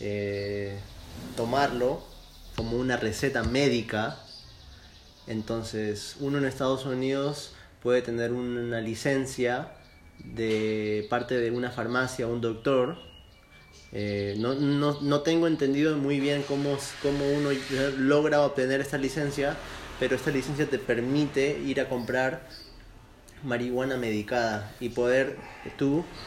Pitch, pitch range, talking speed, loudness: 125 Hz, 115-140 Hz, 115 wpm, -28 LUFS